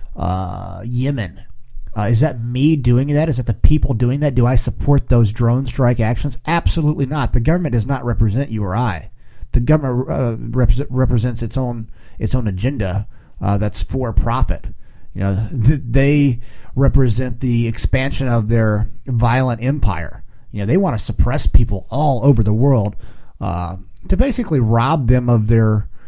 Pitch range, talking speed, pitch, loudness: 105-130 Hz, 170 wpm, 120 Hz, -18 LUFS